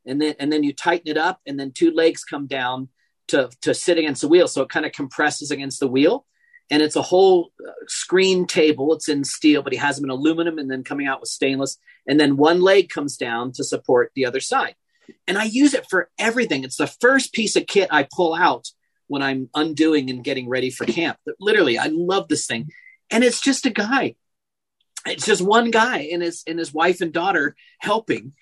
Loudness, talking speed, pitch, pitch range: -20 LUFS, 225 wpm, 160 Hz, 140-215 Hz